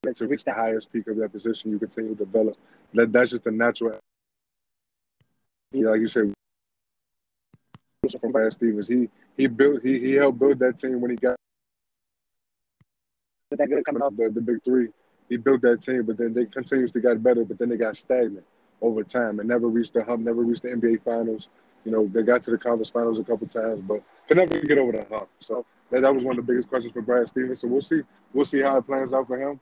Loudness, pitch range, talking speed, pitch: -24 LUFS, 115-125 Hz, 225 wpm, 120 Hz